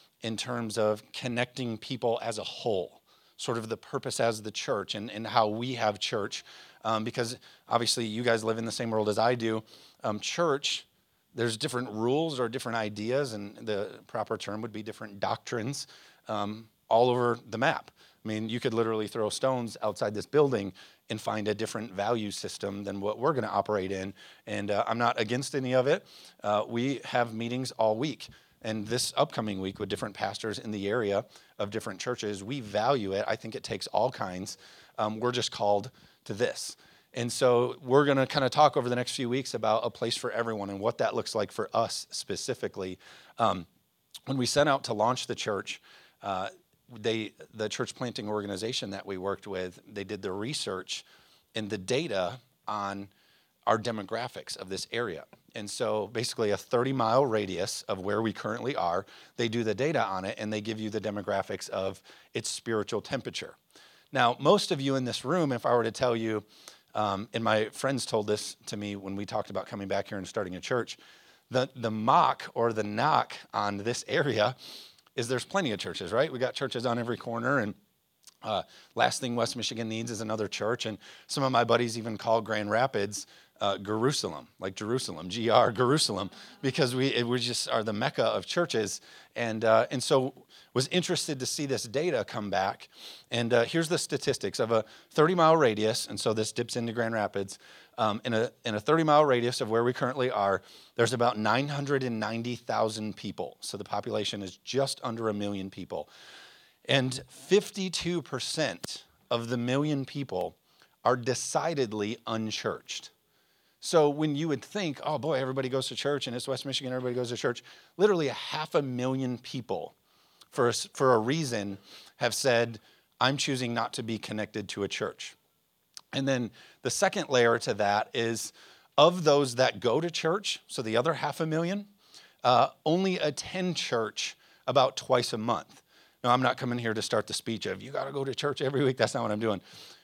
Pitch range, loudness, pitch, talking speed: 105-130 Hz, -30 LUFS, 115 Hz, 190 wpm